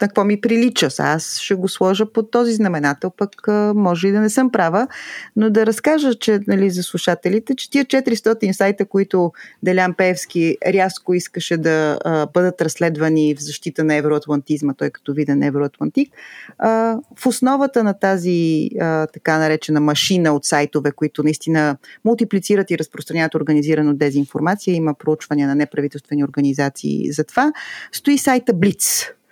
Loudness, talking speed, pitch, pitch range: -18 LUFS, 150 wpm, 180 Hz, 150-210 Hz